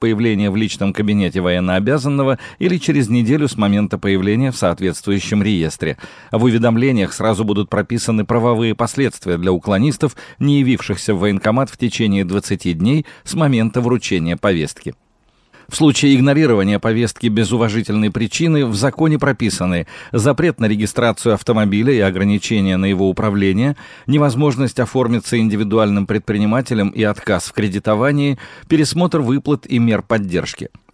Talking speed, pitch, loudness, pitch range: 130 wpm, 110 Hz, -16 LUFS, 100-130 Hz